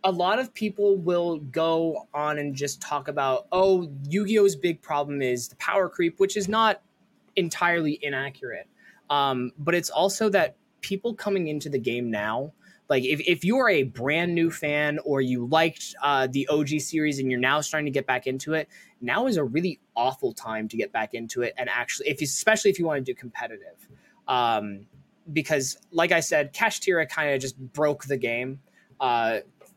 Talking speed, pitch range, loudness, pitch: 190 wpm, 140-185 Hz, -25 LUFS, 150 Hz